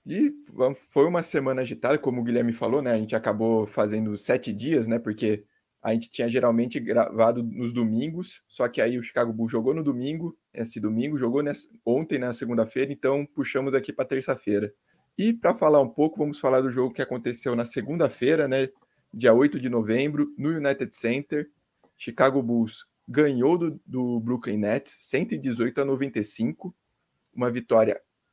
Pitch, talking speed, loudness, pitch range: 130 Hz, 170 wpm, -25 LUFS, 115-145 Hz